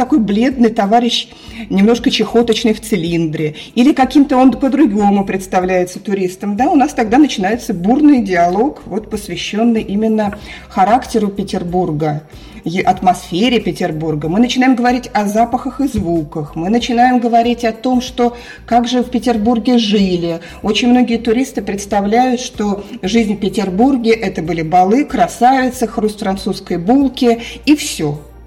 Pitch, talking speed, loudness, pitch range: 225 Hz, 130 wpm, -14 LUFS, 190-245 Hz